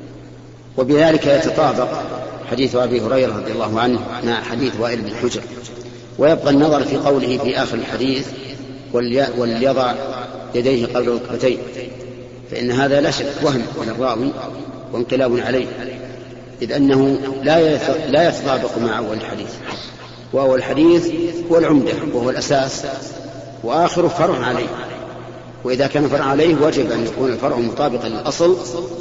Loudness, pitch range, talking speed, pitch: -18 LUFS, 120-140 Hz, 120 wpm, 130 Hz